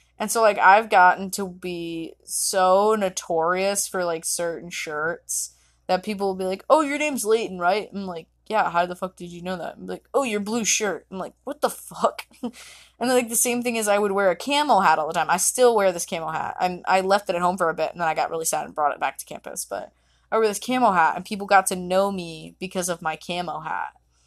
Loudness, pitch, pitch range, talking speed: -22 LUFS, 185 Hz, 175-215 Hz, 255 wpm